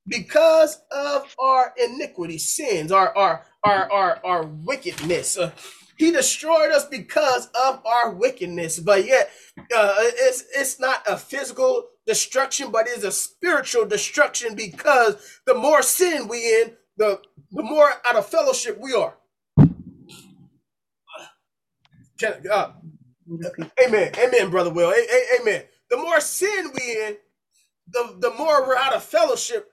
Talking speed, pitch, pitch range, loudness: 135 wpm, 265 Hz, 215-325 Hz, -20 LUFS